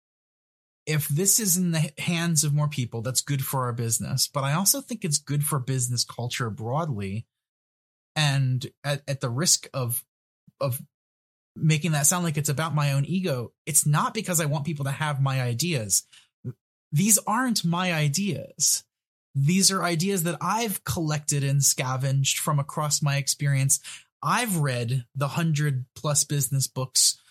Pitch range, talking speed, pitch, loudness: 130-170 Hz, 160 wpm, 145 Hz, -24 LUFS